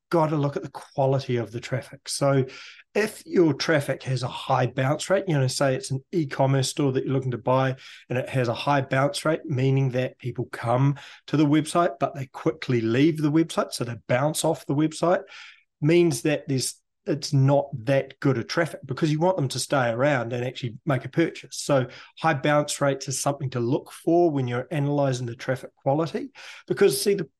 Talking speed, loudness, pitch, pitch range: 210 wpm, -25 LUFS, 140 Hz, 130-155 Hz